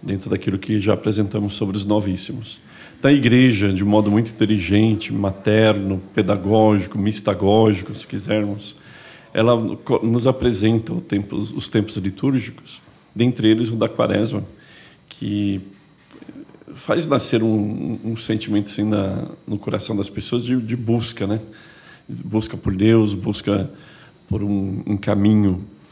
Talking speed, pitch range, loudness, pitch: 130 wpm, 100-115 Hz, -20 LUFS, 105 Hz